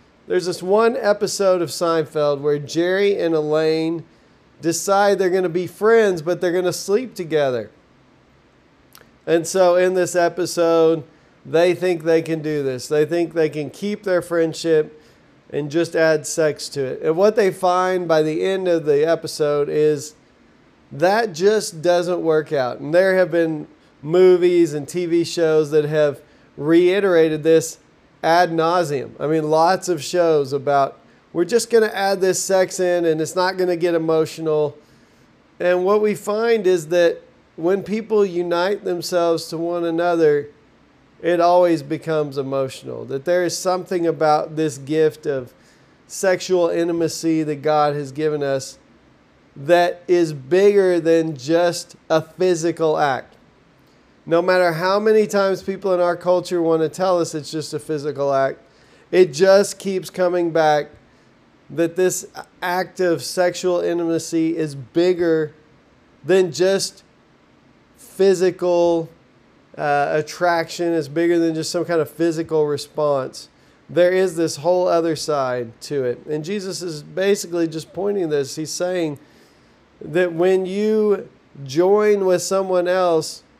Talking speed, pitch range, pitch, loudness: 150 wpm, 155-180 Hz, 170 Hz, -19 LUFS